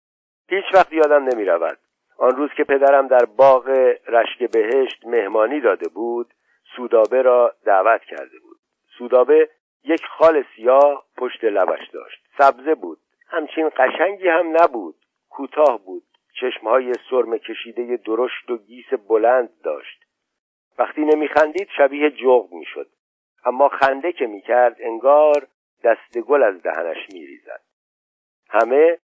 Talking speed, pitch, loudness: 130 wpm, 155 Hz, -18 LUFS